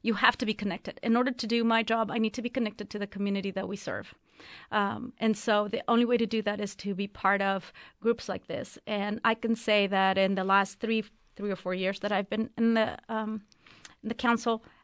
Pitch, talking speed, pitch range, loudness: 215 Hz, 245 wpm, 200-230 Hz, -29 LUFS